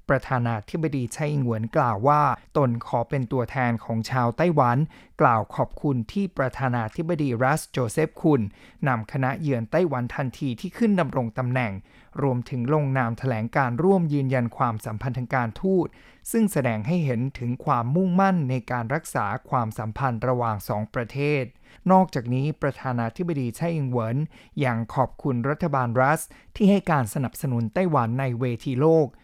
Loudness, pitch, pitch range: -24 LUFS, 130 Hz, 120-150 Hz